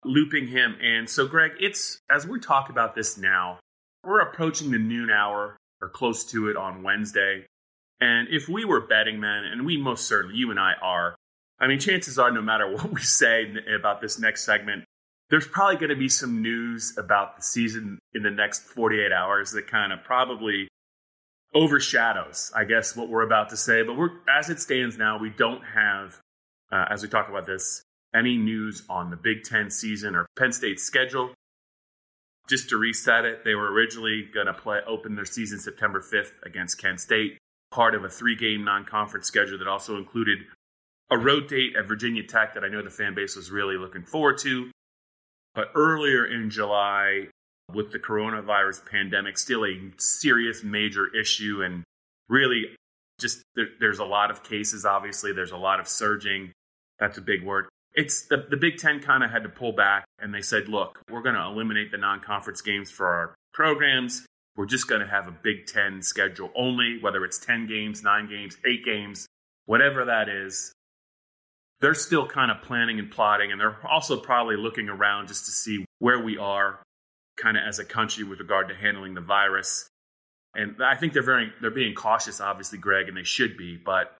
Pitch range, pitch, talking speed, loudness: 100-115 Hz, 105 Hz, 190 wpm, -24 LUFS